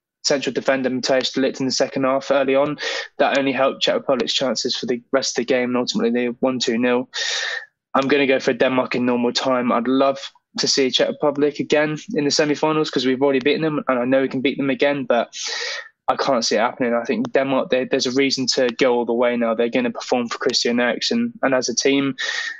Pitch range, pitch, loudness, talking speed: 125-145 Hz, 135 Hz, -20 LUFS, 240 wpm